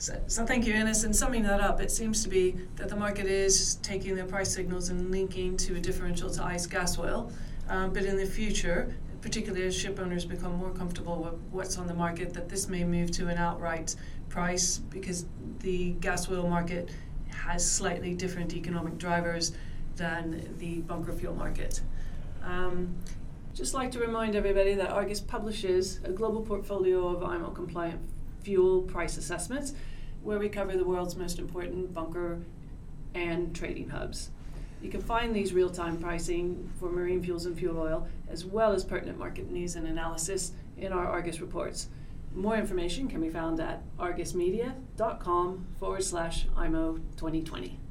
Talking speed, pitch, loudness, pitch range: 170 wpm, 180 Hz, -32 LUFS, 170-190 Hz